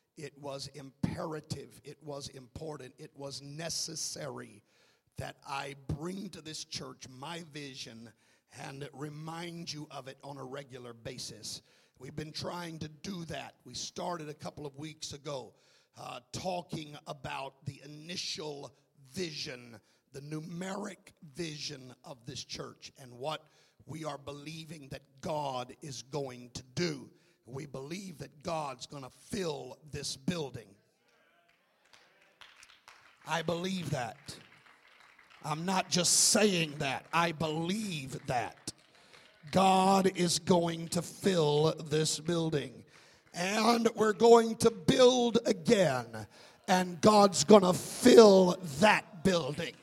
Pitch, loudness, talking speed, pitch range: 155 Hz, -30 LUFS, 125 wpm, 140-175 Hz